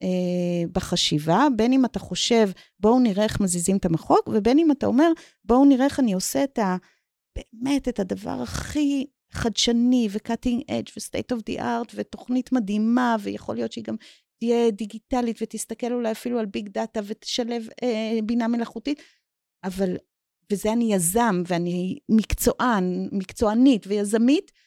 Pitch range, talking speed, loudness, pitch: 195-245 Hz, 145 wpm, -23 LUFS, 225 Hz